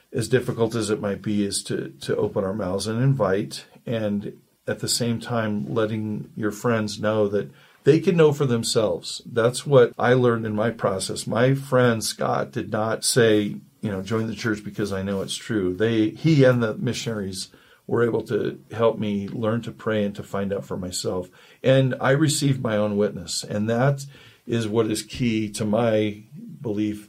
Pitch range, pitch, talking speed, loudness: 105-120 Hz, 110 Hz, 190 wpm, -23 LUFS